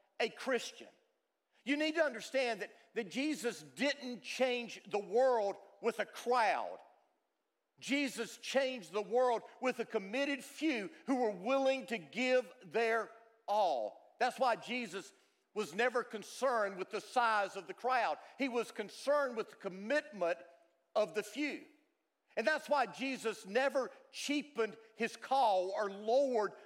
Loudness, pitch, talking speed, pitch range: -36 LUFS, 235 Hz, 140 wpm, 210-270 Hz